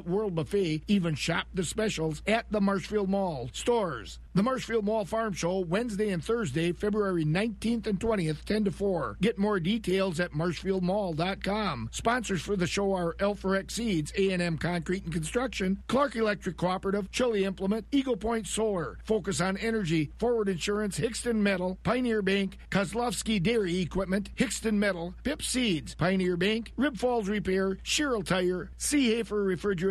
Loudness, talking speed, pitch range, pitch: -29 LUFS, 155 wpm, 180-220 Hz, 195 Hz